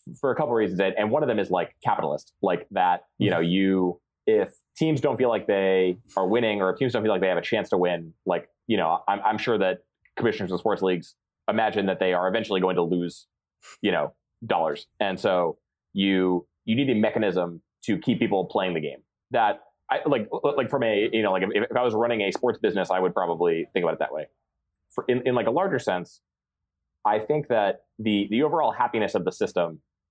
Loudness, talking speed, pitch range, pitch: -25 LUFS, 230 wpm, 90-115 Hz, 95 Hz